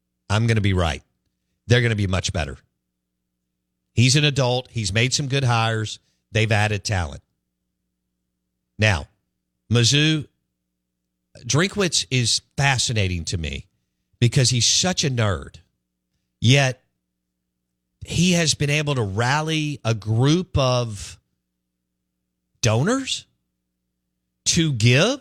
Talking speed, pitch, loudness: 110 wpm, 100 Hz, -20 LUFS